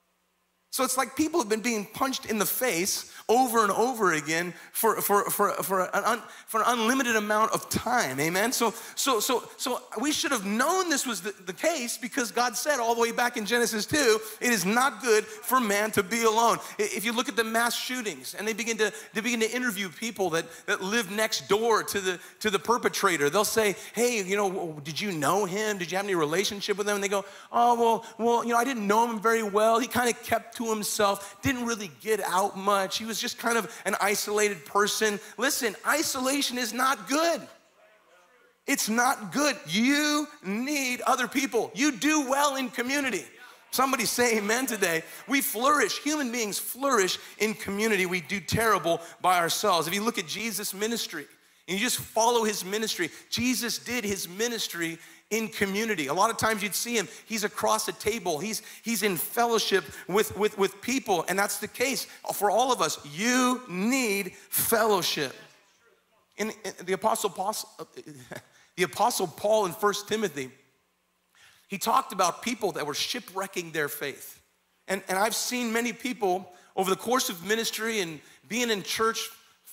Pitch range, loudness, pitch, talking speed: 195-240 Hz, -27 LUFS, 220 Hz, 185 wpm